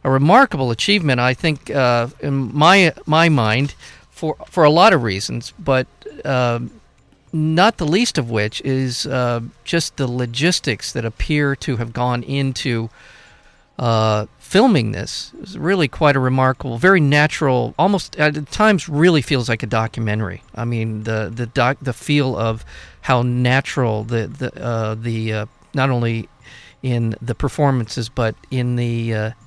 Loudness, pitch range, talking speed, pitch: -18 LUFS, 115-150 Hz, 155 wpm, 130 Hz